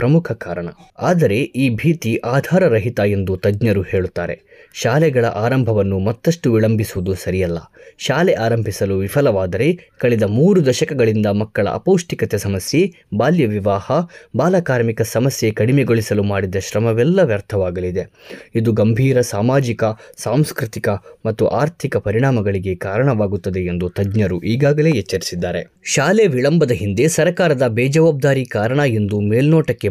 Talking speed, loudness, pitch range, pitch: 100 wpm, -17 LUFS, 100-140 Hz, 115 Hz